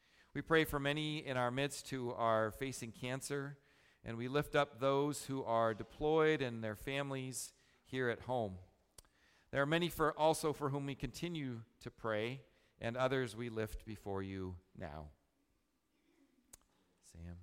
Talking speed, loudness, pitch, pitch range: 150 wpm, -39 LUFS, 130 Hz, 110-145 Hz